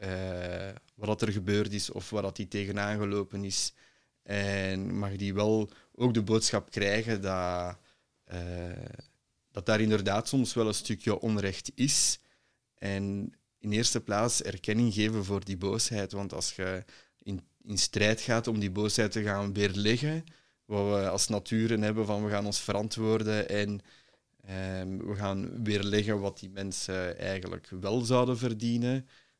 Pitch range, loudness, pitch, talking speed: 100-110 Hz, -31 LUFS, 105 Hz, 155 wpm